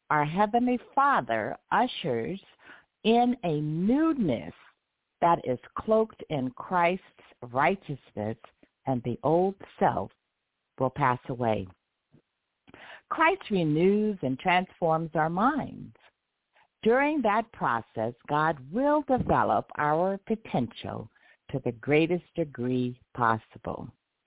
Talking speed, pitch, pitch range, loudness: 95 wpm, 165 Hz, 130-215 Hz, -28 LUFS